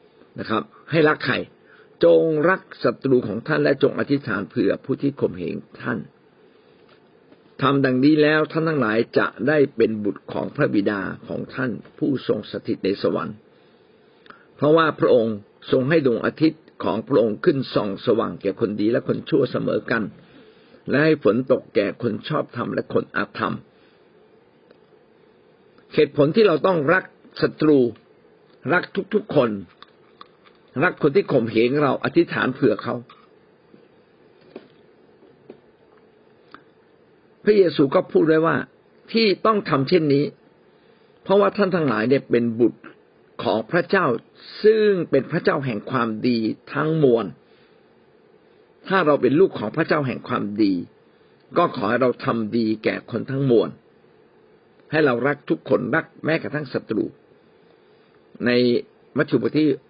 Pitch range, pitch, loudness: 130-215 Hz, 155 Hz, -21 LUFS